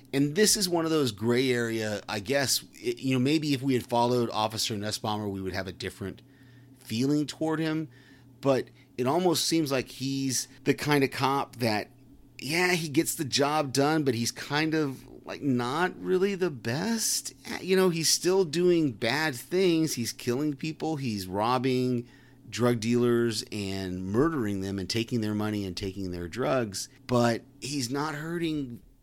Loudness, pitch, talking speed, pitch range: -28 LUFS, 130 Hz, 170 wpm, 115-150 Hz